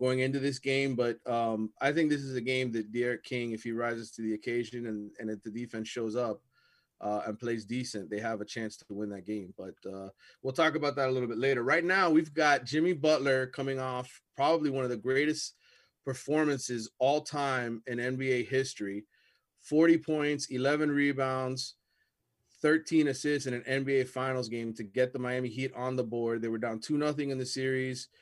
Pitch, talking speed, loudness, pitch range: 130 Hz, 205 wpm, -31 LUFS, 115-140 Hz